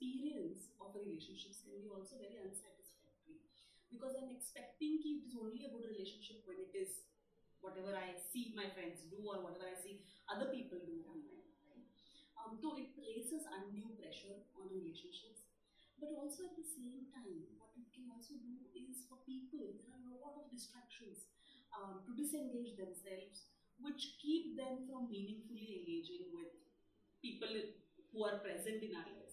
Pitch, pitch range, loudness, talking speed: 245 Hz, 205-290 Hz, -50 LUFS, 170 wpm